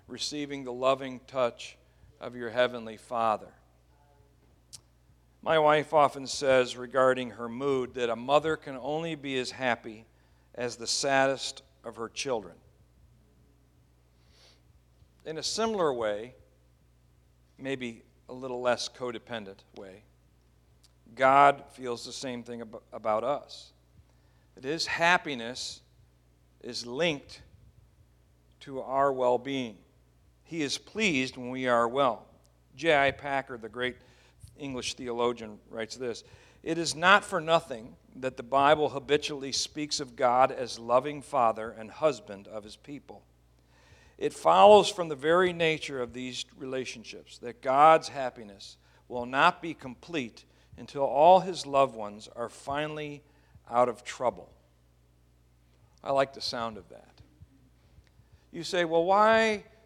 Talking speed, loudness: 125 wpm, -28 LUFS